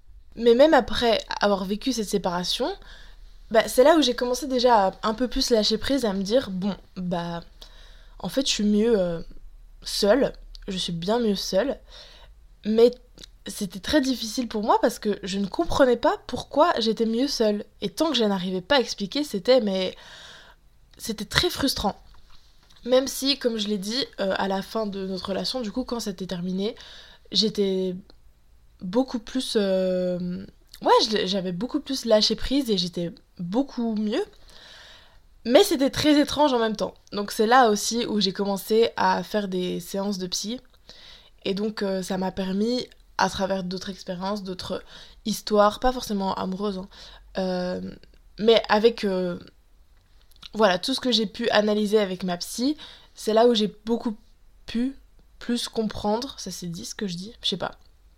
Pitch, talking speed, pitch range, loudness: 210 Hz, 170 wpm, 190-245 Hz, -24 LUFS